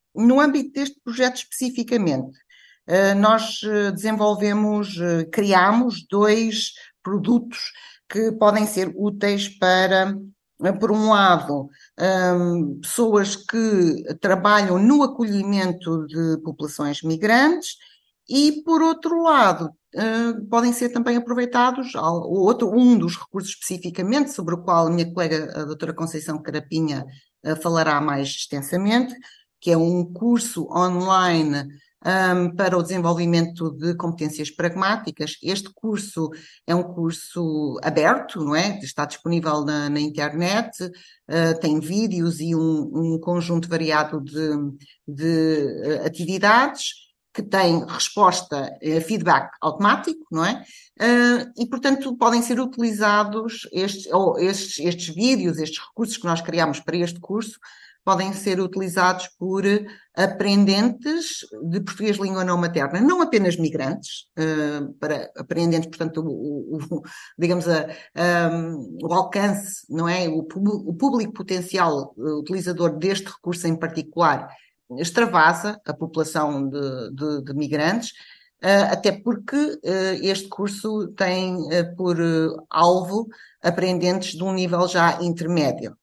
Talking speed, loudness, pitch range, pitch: 115 wpm, -21 LUFS, 160-215 Hz, 185 Hz